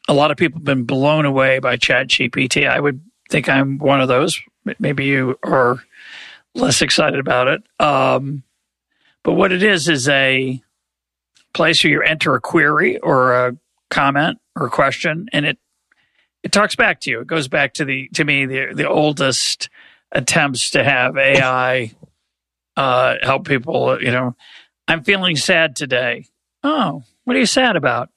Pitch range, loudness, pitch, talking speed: 125-160 Hz, -16 LUFS, 135 Hz, 170 wpm